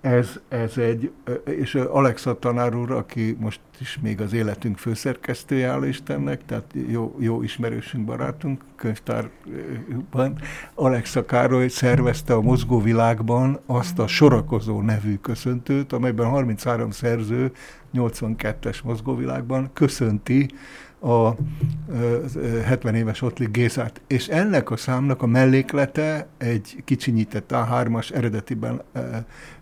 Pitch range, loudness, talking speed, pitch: 115-130 Hz, -23 LUFS, 105 wpm, 120 Hz